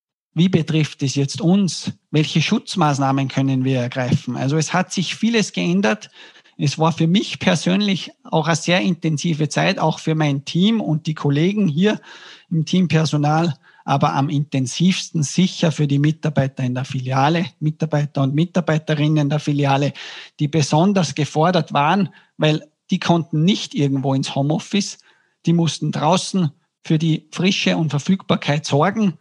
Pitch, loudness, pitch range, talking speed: 155 Hz, -19 LUFS, 145-180 Hz, 145 wpm